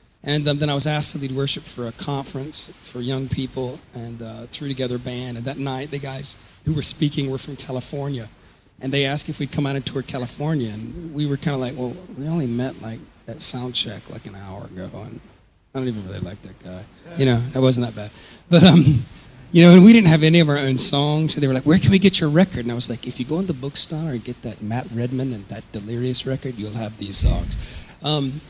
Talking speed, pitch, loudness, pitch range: 255 wpm, 130 Hz, -19 LUFS, 120-145 Hz